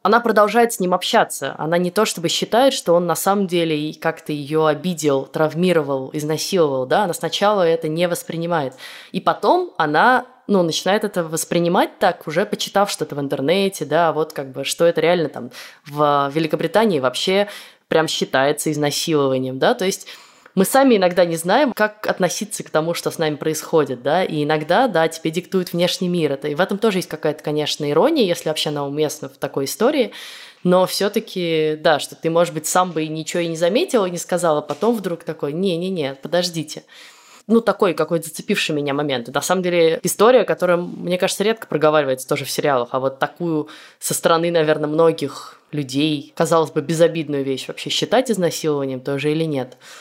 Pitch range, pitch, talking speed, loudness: 150-185 Hz, 165 Hz, 185 wpm, -19 LUFS